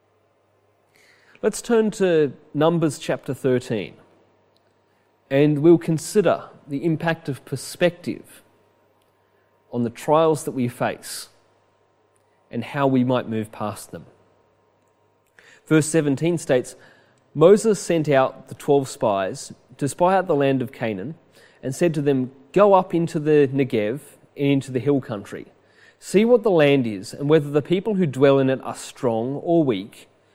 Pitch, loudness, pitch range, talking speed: 140 Hz, -21 LUFS, 115-165 Hz, 145 wpm